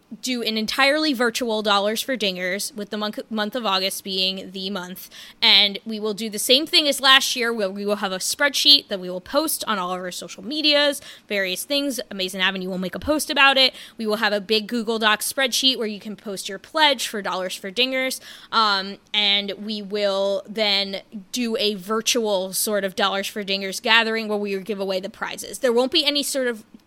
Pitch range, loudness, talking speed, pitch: 195-255 Hz, -20 LUFS, 215 wpm, 215 Hz